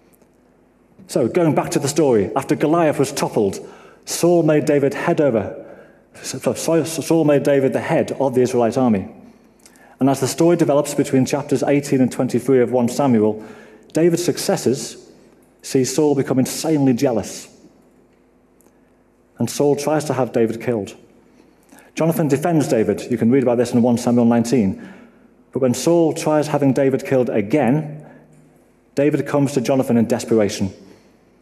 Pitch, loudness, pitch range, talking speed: 135 Hz, -18 LUFS, 120-145 Hz, 145 wpm